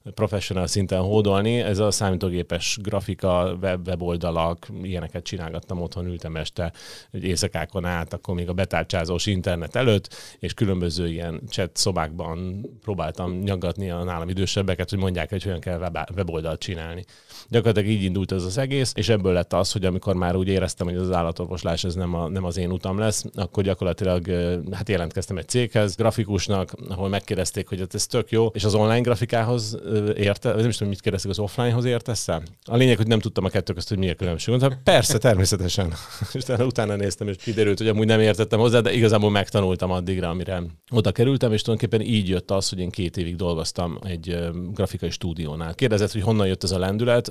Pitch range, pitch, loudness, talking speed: 90-105 Hz, 95 Hz, -24 LUFS, 185 wpm